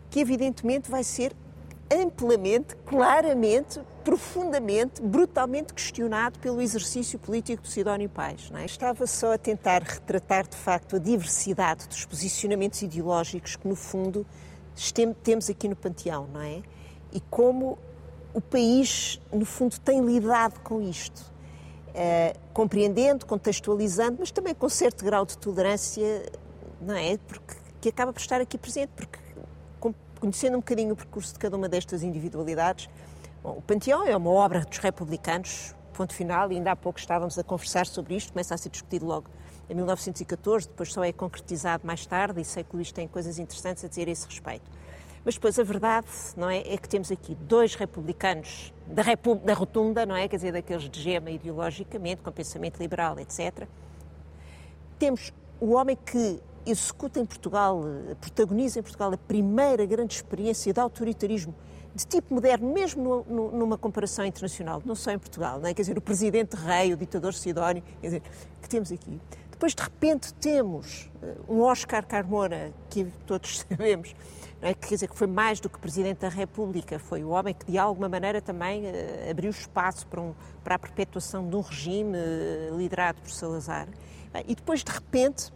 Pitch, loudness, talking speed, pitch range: 200 Hz, -28 LUFS, 170 wpm, 175-230 Hz